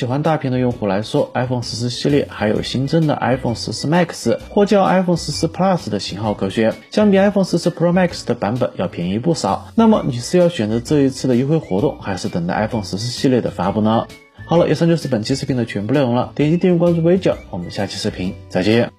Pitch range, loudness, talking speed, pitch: 110-170 Hz, -18 LUFS, 450 characters per minute, 135 Hz